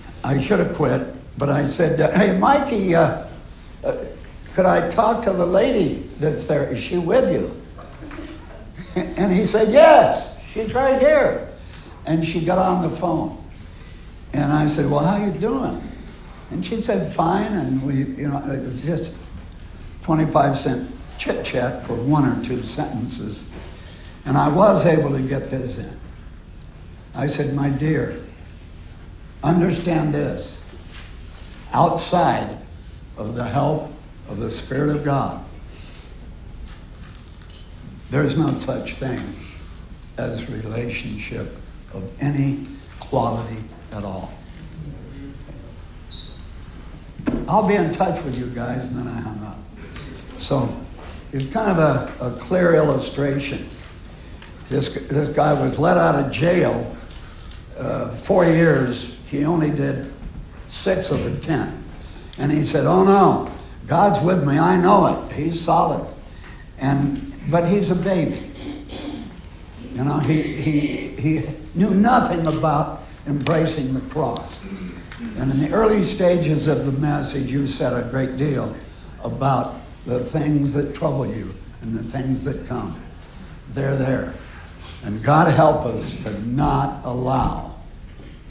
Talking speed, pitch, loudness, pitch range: 135 wpm, 140 Hz, -20 LUFS, 110-165 Hz